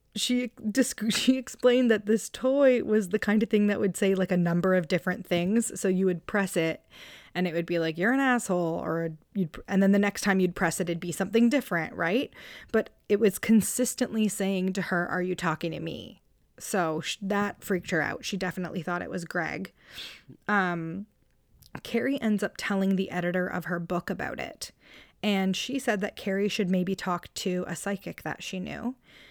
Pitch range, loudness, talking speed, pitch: 180-215 Hz, -28 LUFS, 200 wpm, 195 Hz